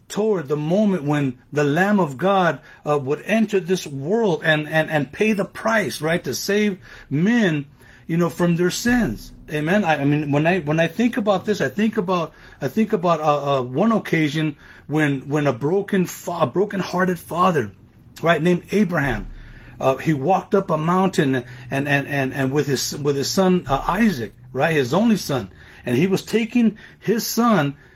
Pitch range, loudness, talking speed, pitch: 140-195 Hz, -20 LUFS, 185 wpm, 165 Hz